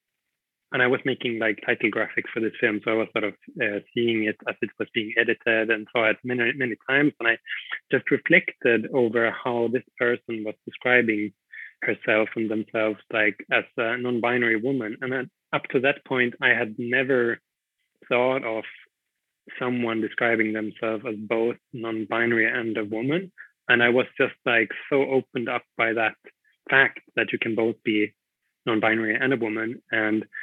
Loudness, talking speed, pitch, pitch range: -24 LUFS, 175 wpm, 115 Hz, 110-125 Hz